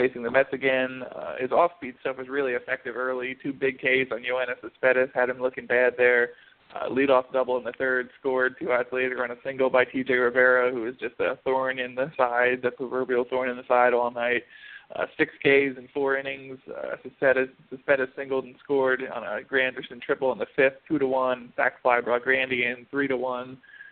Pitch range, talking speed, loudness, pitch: 125-135 Hz, 210 wpm, -25 LUFS, 130 Hz